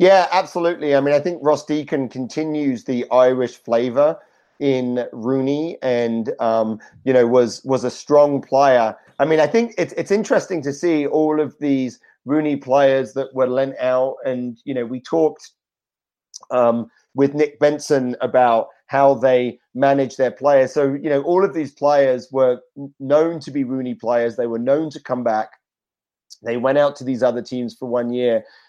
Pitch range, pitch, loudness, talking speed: 125-150 Hz, 135 Hz, -19 LUFS, 180 wpm